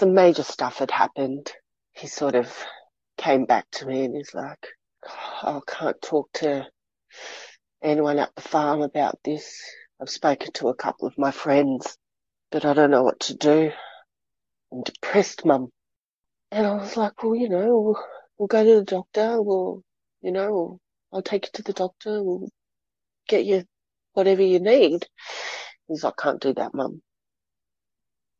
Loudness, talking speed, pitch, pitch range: -23 LUFS, 165 wpm, 180 Hz, 145-205 Hz